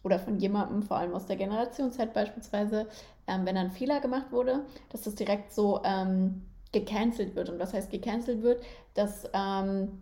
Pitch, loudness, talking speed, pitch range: 205 Hz, -31 LUFS, 175 wpm, 195-230 Hz